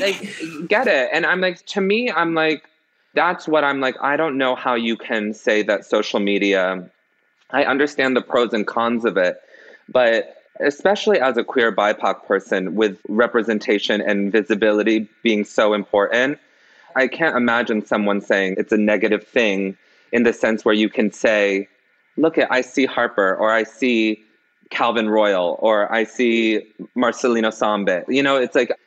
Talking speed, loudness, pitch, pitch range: 170 wpm, -19 LUFS, 115 Hz, 105-135 Hz